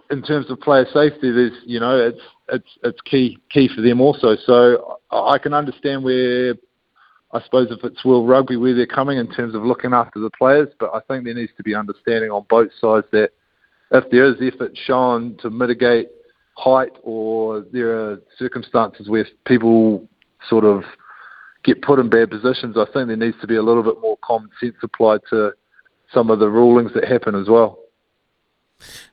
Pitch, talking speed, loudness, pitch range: 120 Hz, 190 wpm, -17 LUFS, 110-130 Hz